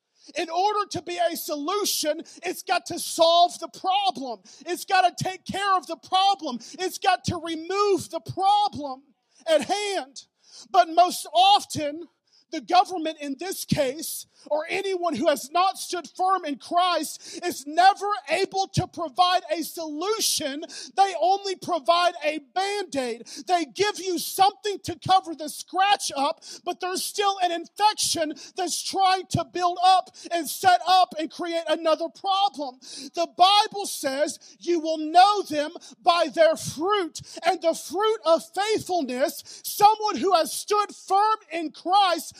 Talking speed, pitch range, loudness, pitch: 150 wpm, 315-375 Hz, -24 LUFS, 345 Hz